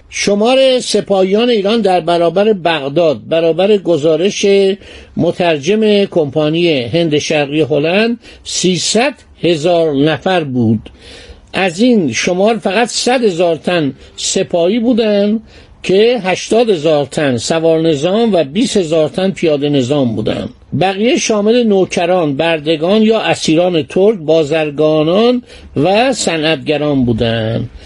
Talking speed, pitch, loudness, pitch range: 110 wpm, 175 Hz, -12 LUFS, 155-210 Hz